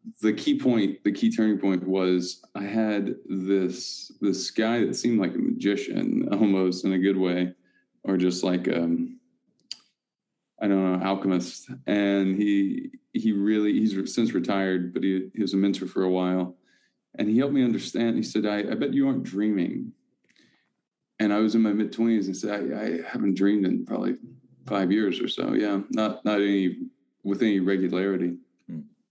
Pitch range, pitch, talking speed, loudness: 95-110 Hz, 100 Hz, 175 wpm, -25 LUFS